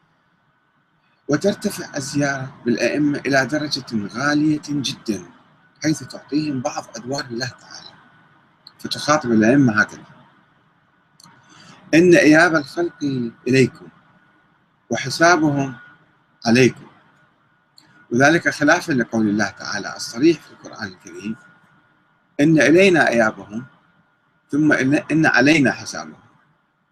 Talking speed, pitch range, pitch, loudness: 85 wpm, 125-155 Hz, 145 Hz, -18 LUFS